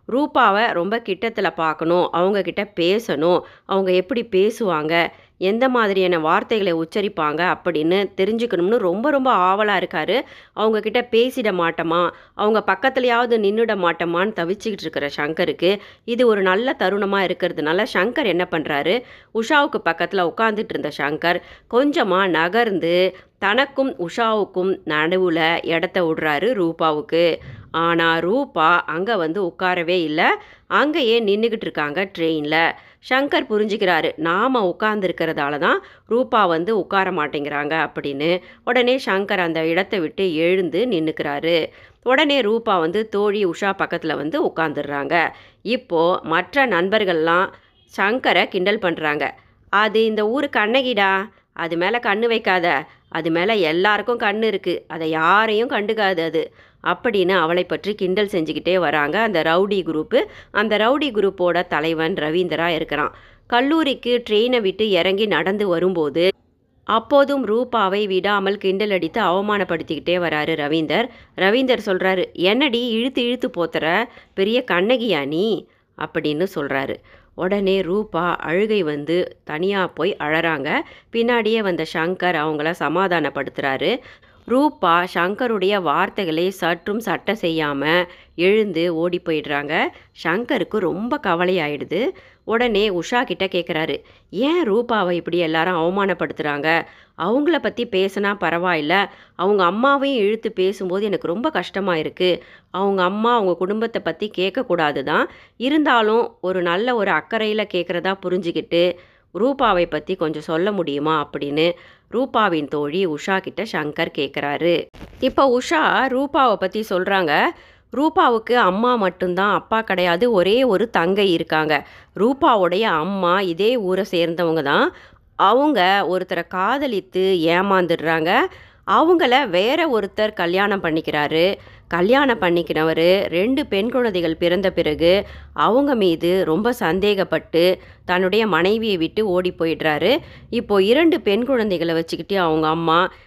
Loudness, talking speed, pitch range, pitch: -19 LUFS, 115 wpm, 165-215 Hz, 185 Hz